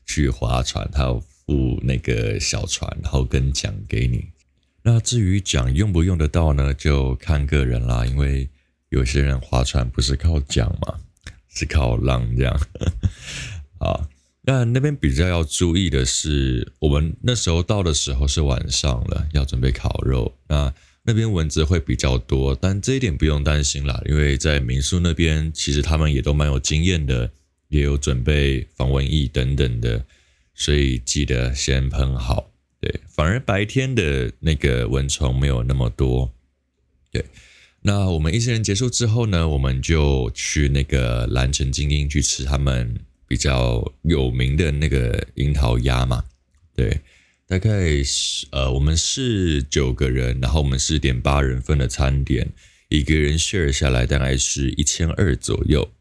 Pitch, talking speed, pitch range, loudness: 70 Hz, 240 characters per minute, 65-85 Hz, -21 LUFS